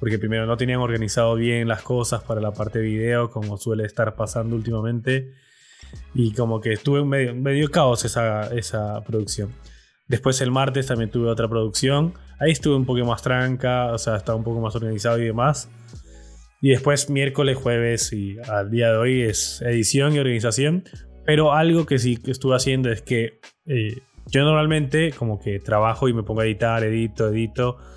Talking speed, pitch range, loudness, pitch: 180 wpm, 110-130 Hz, -22 LUFS, 120 Hz